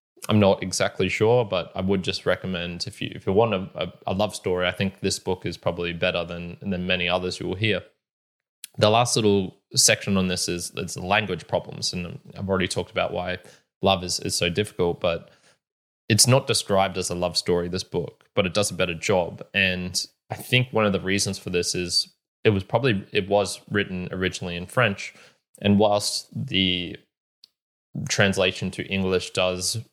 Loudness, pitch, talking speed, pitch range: -24 LUFS, 95 Hz, 190 wpm, 90-105 Hz